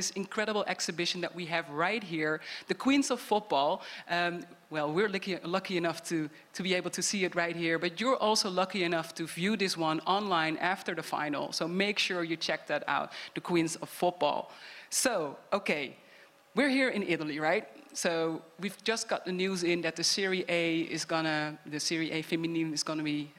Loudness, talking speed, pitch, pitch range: -31 LUFS, 200 wpm, 175 Hz, 160-195 Hz